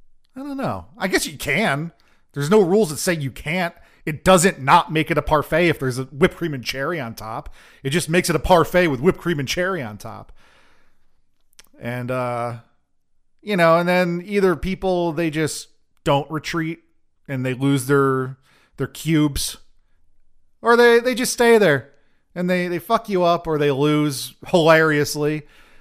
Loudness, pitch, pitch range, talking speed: -19 LUFS, 155 Hz, 135-180 Hz, 180 wpm